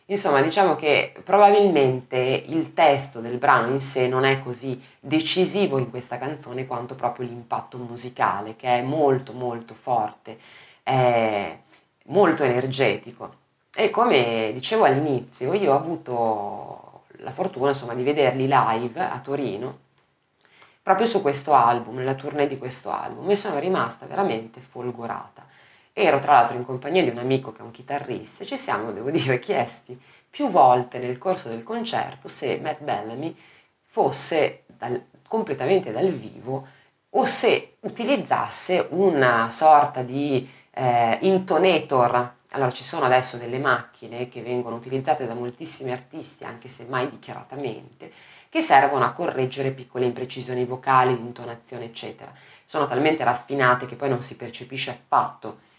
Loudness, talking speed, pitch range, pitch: -23 LUFS, 140 wpm, 120-145 Hz, 130 Hz